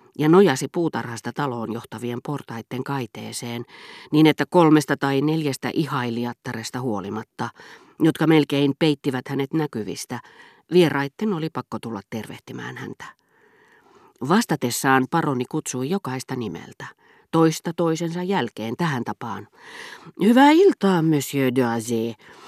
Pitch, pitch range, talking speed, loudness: 140 Hz, 125-170 Hz, 105 wpm, -22 LUFS